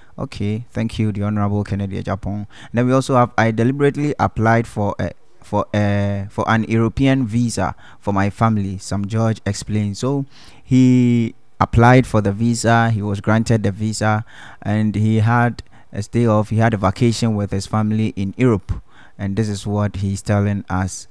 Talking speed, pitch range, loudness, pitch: 175 wpm, 100-115 Hz, -18 LUFS, 110 Hz